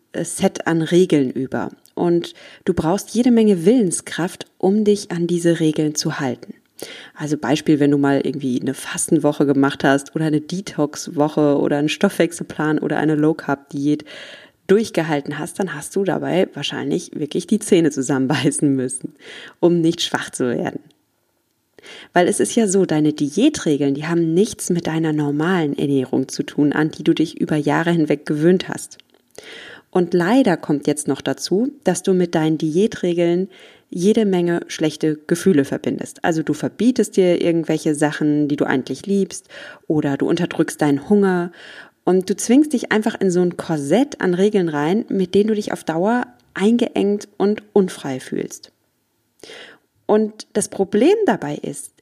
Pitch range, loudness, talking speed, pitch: 150-195 Hz, -19 LUFS, 160 wpm, 170 Hz